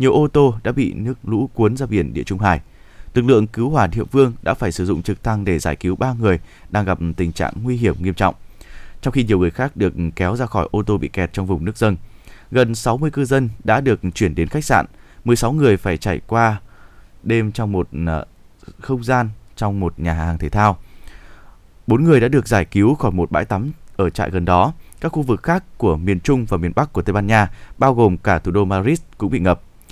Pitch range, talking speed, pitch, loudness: 90-120 Hz, 235 wpm, 105 Hz, -18 LUFS